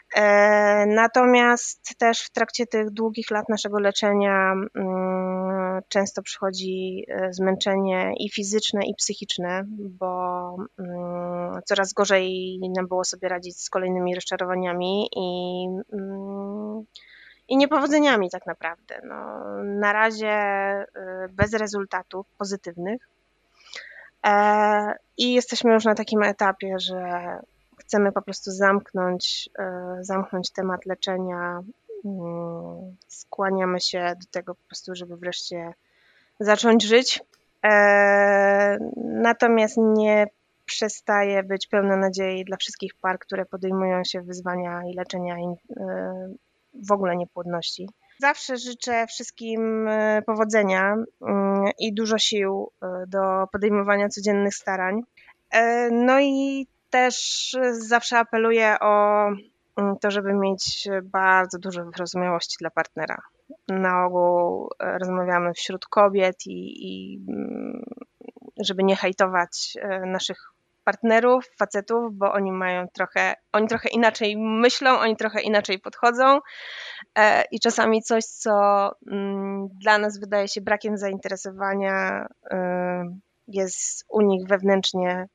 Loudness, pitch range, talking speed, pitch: -23 LUFS, 185-220 Hz, 100 wpm, 200 Hz